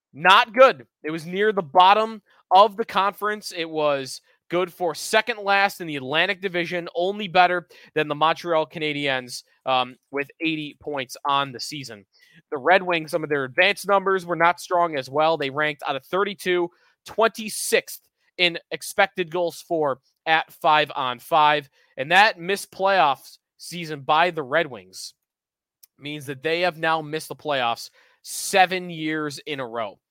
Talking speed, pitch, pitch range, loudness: 165 wpm, 165 Hz, 150-185 Hz, -22 LUFS